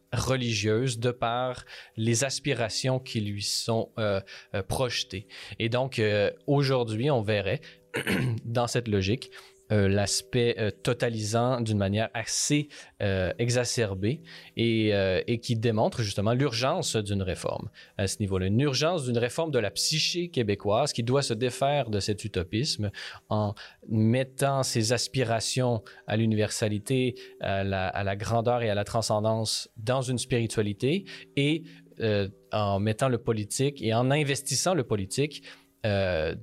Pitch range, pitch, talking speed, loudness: 105-130 Hz, 115 Hz, 140 wpm, -28 LUFS